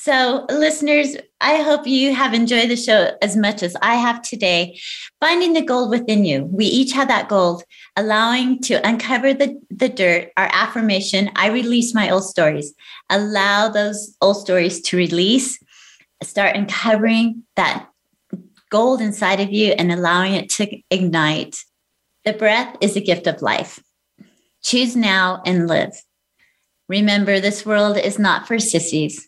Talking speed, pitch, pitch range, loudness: 150 wpm, 210 Hz, 190-240 Hz, -17 LUFS